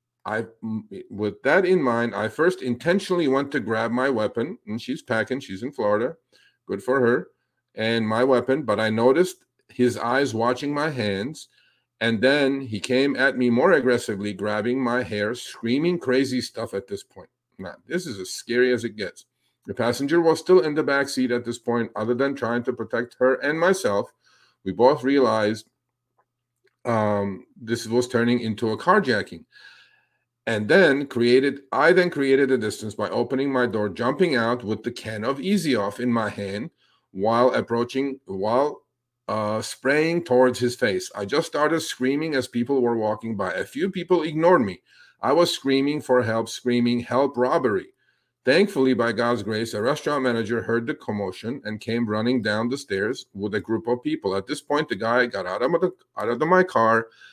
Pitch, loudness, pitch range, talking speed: 125 Hz, -23 LUFS, 115-140 Hz, 180 wpm